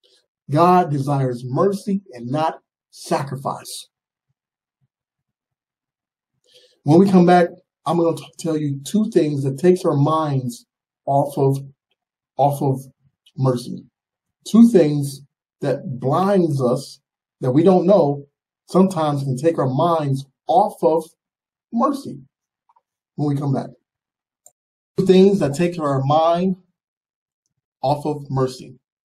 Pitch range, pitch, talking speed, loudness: 140-180 Hz, 150 Hz, 115 wpm, -19 LUFS